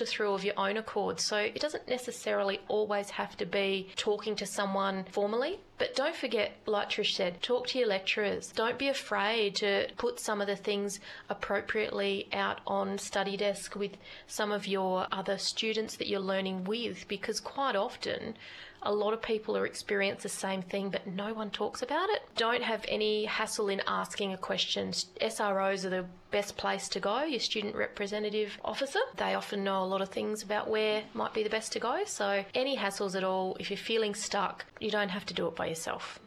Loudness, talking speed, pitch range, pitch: -32 LUFS, 200 wpm, 195-220 Hz, 205 Hz